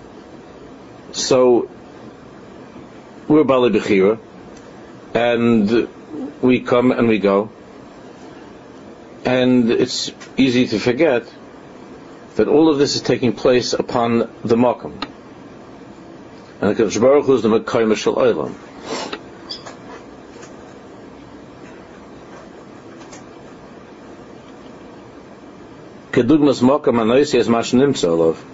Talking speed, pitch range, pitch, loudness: 75 wpm, 115-130 Hz, 125 Hz, -16 LUFS